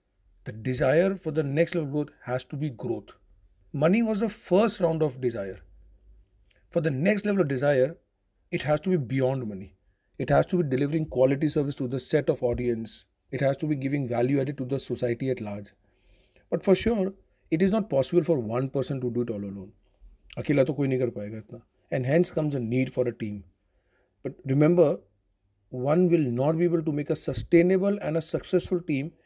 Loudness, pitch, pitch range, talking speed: -26 LUFS, 135 Hz, 115-160 Hz, 190 wpm